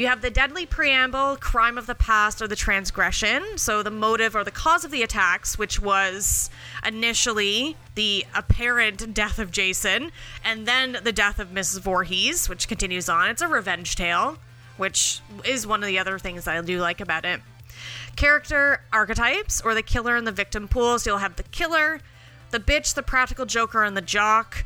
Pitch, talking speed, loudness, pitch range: 220 Hz, 190 wpm, -22 LUFS, 195-245 Hz